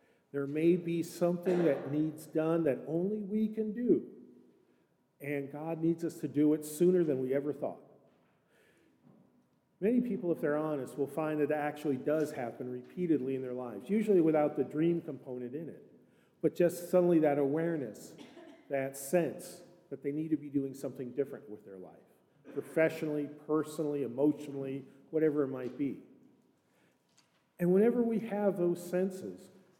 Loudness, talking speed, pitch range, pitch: -33 LUFS, 155 wpm, 140-175 Hz, 155 Hz